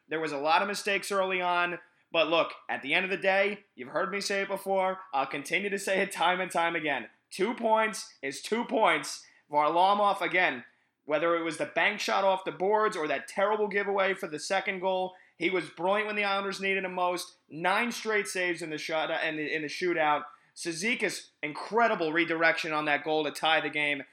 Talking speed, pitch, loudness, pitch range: 215 wpm, 180 Hz, -29 LUFS, 160-195 Hz